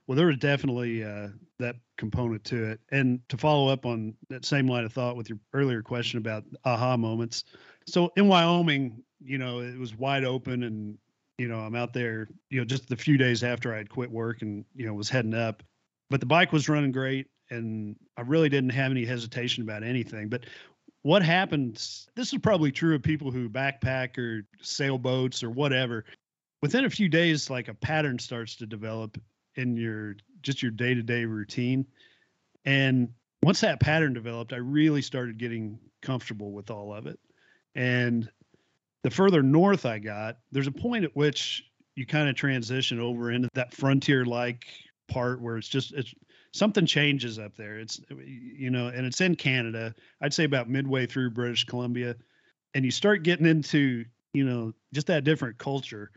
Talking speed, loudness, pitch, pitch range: 185 wpm, -27 LUFS, 125 Hz, 115-140 Hz